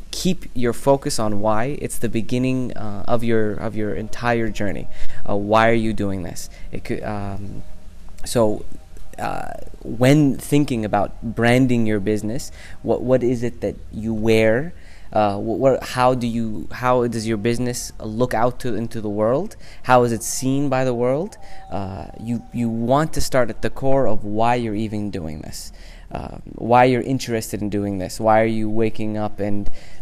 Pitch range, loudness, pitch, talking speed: 105-125 Hz, -21 LUFS, 110 Hz, 180 wpm